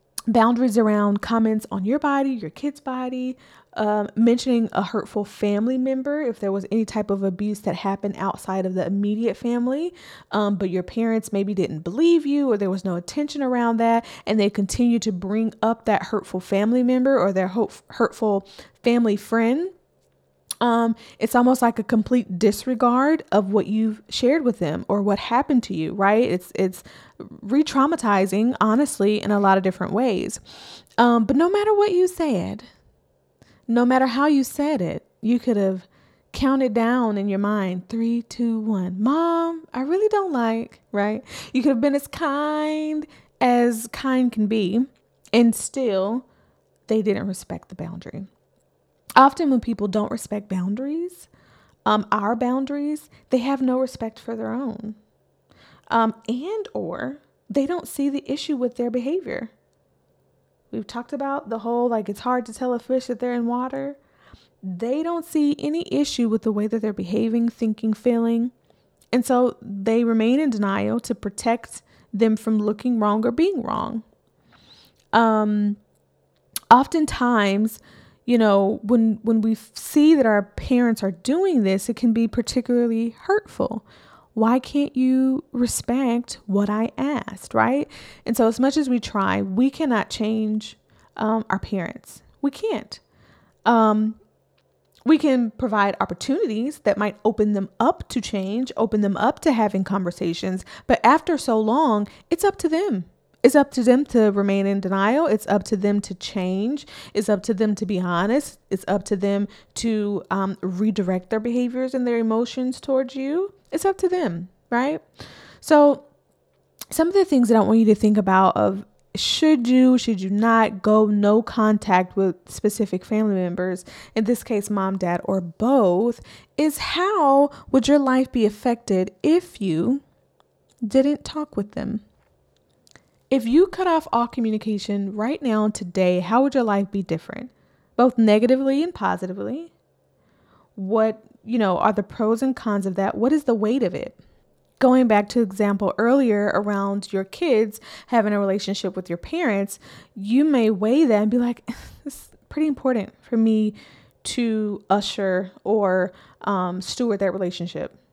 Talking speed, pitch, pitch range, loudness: 165 wpm, 230 Hz, 205-260 Hz, -21 LUFS